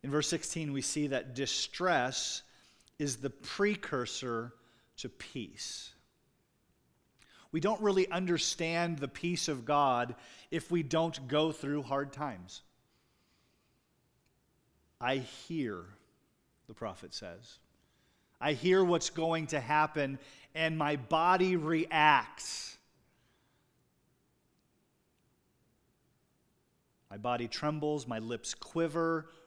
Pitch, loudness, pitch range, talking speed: 150 Hz, -33 LUFS, 130-165 Hz, 100 wpm